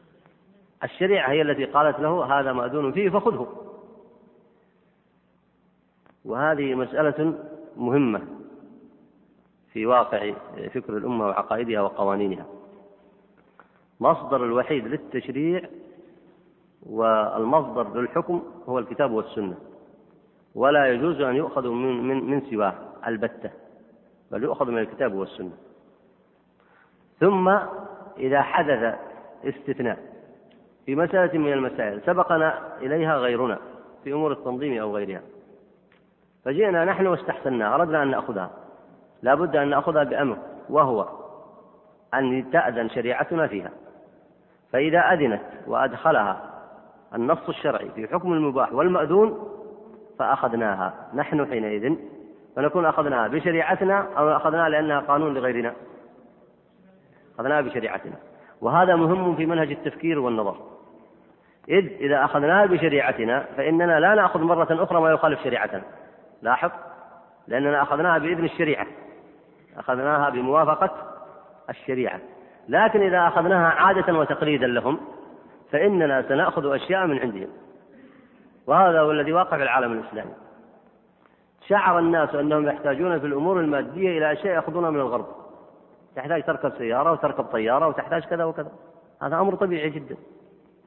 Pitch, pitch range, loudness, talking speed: 155 Hz, 130-175 Hz, -23 LUFS, 105 wpm